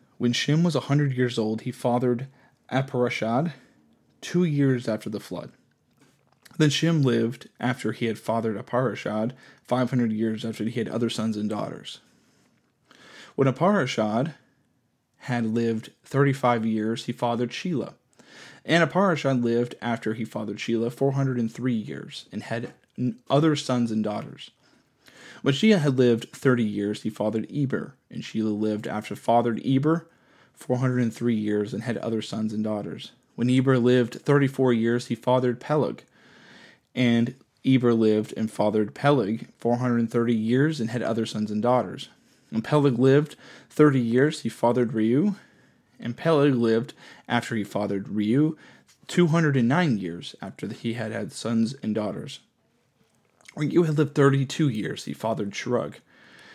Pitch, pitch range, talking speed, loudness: 120 Hz, 110-135 Hz, 145 wpm, -25 LUFS